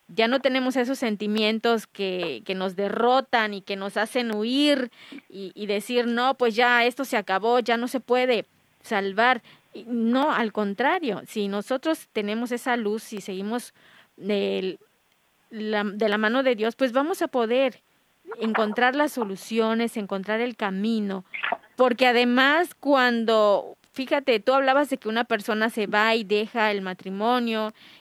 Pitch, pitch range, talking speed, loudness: 230 Hz, 210-250 Hz, 155 wpm, -24 LUFS